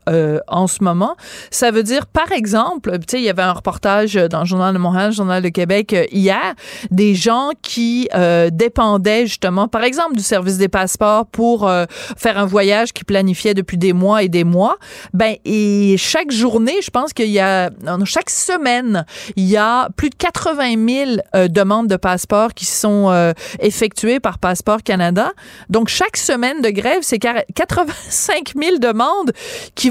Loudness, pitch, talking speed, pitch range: -15 LUFS, 210 Hz, 180 wpm, 190-240 Hz